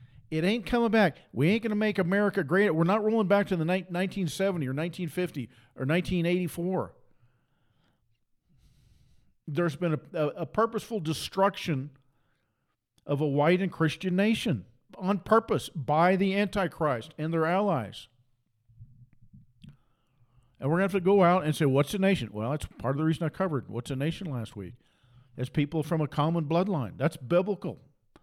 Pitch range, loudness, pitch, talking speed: 130-190 Hz, -28 LUFS, 160 Hz, 165 wpm